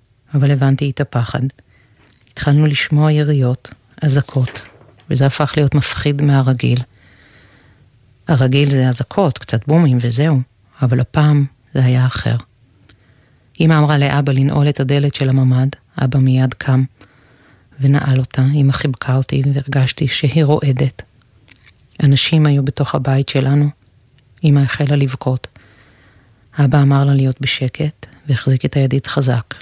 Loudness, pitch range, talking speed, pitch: -15 LUFS, 120-145 Hz, 120 wpm, 135 Hz